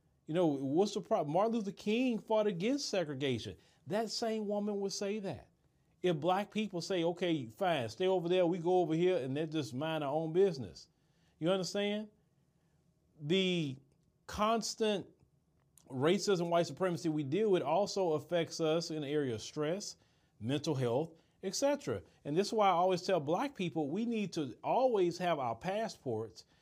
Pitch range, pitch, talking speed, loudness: 155-200 Hz, 175 Hz, 165 wpm, -34 LUFS